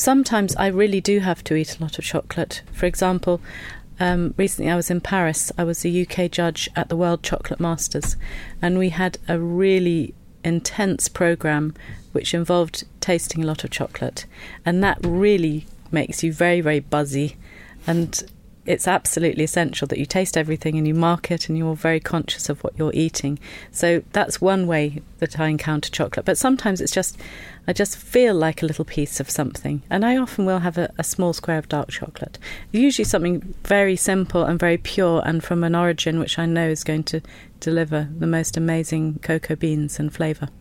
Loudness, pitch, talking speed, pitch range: -21 LUFS, 165 Hz, 190 wpm, 155-180 Hz